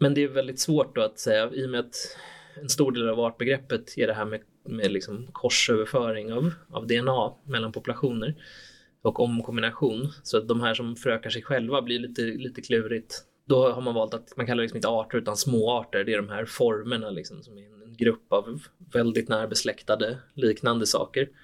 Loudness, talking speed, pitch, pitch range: -27 LUFS, 200 wpm, 120 Hz, 115-130 Hz